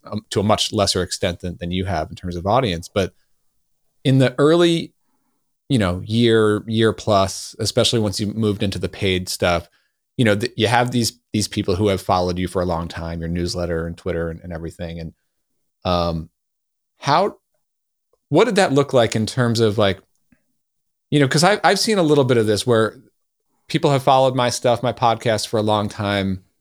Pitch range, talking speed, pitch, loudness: 90-120 Hz, 200 wpm, 105 Hz, -19 LUFS